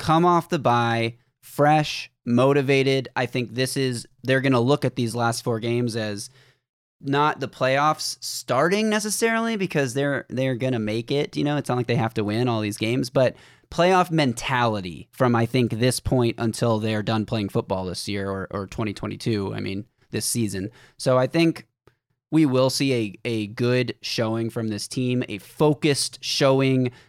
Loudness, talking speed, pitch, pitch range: -23 LUFS, 175 wpm, 125 Hz, 115-135 Hz